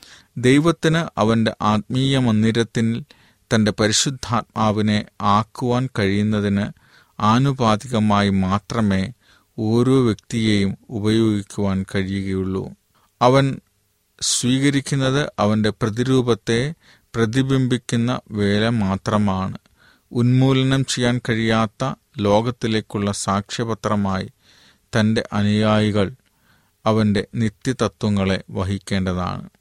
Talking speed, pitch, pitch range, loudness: 65 wpm, 110 Hz, 100-120 Hz, -20 LUFS